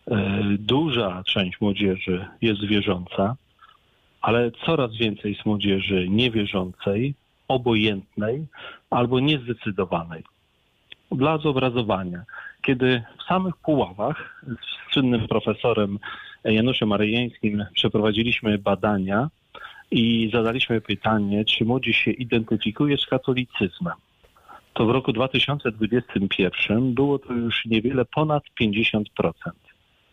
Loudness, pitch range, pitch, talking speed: -23 LUFS, 105-125 Hz, 115 Hz, 90 wpm